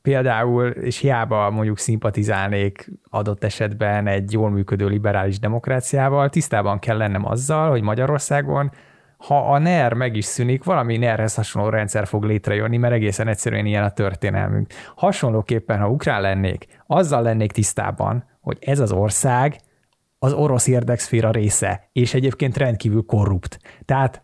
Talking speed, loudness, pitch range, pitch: 140 wpm, -20 LUFS, 105-130 Hz, 115 Hz